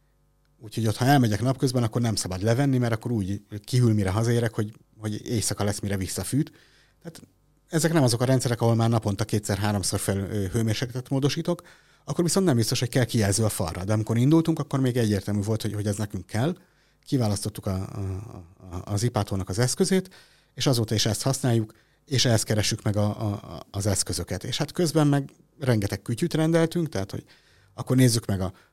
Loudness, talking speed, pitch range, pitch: -25 LUFS, 185 wpm, 105-140 Hz, 115 Hz